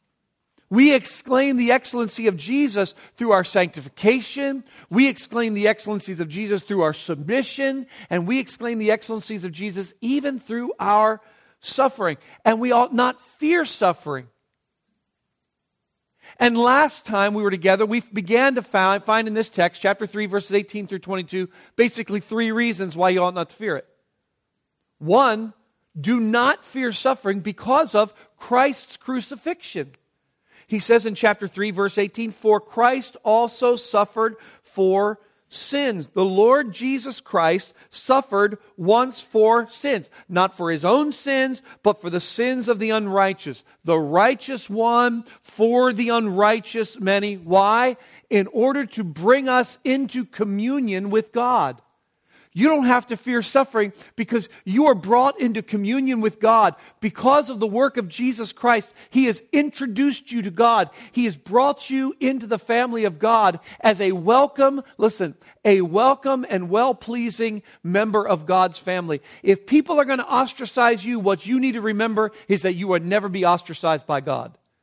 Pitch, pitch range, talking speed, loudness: 225 Hz, 200-250 Hz, 155 wpm, -21 LUFS